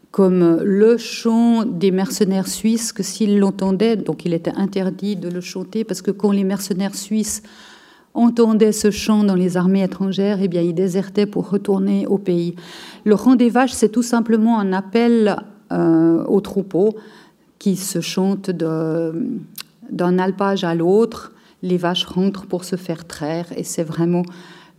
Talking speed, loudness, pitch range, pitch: 160 wpm, -18 LUFS, 180-215 Hz, 195 Hz